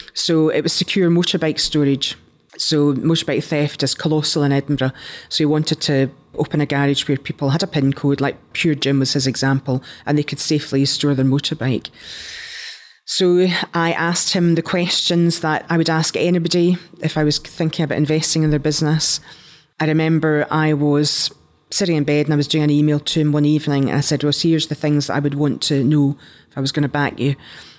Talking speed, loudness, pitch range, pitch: 205 wpm, -18 LUFS, 145-165 Hz, 150 Hz